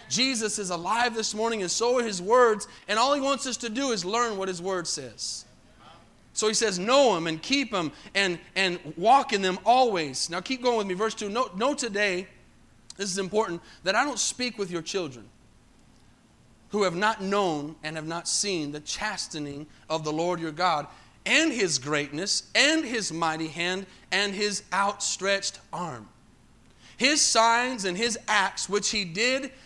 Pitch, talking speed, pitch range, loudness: 200 Hz, 185 wpm, 180-235 Hz, -26 LUFS